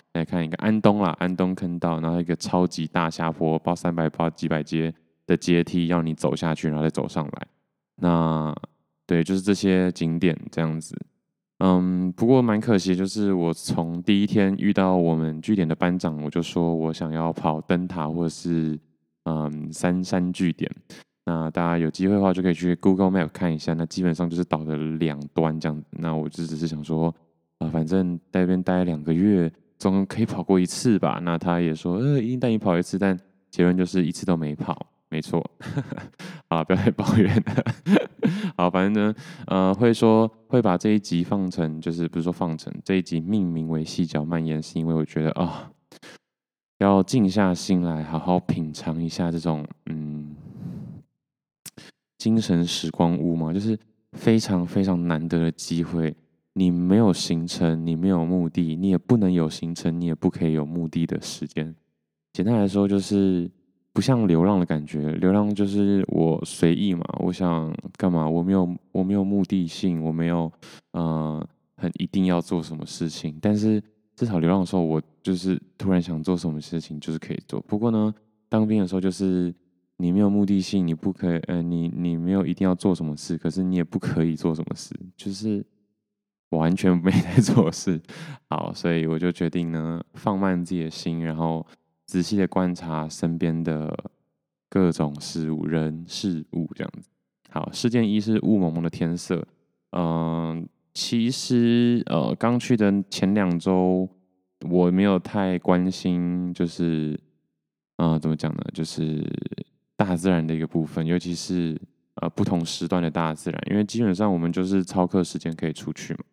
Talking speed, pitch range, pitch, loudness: 265 characters per minute, 80-95 Hz, 85 Hz, -24 LUFS